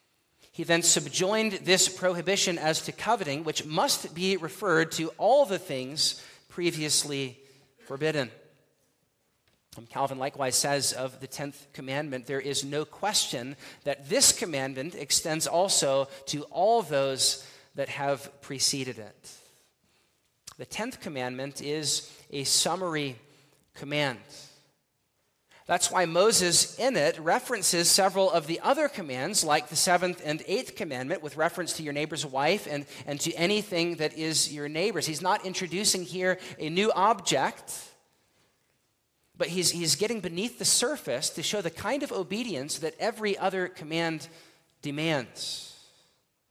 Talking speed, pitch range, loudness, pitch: 135 wpm, 140-185 Hz, -27 LUFS, 155 Hz